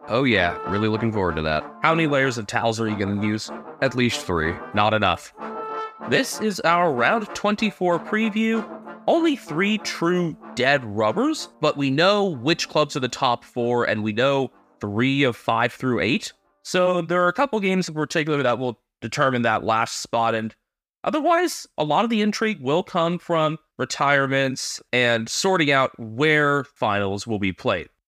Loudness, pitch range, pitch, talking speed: -22 LUFS, 115-180 Hz, 140 Hz, 175 wpm